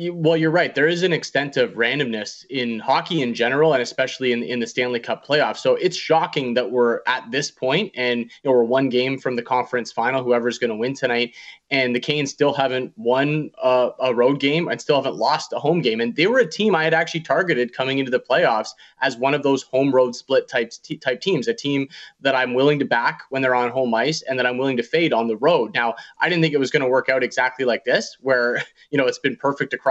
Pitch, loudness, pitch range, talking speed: 130 Hz, -20 LUFS, 125-155 Hz, 255 wpm